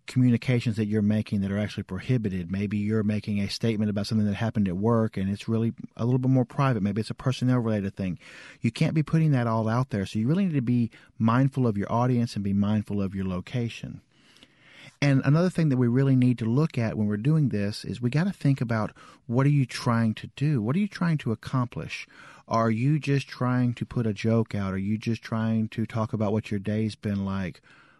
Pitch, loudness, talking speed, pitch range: 115 Hz, -26 LUFS, 235 wpm, 105-130 Hz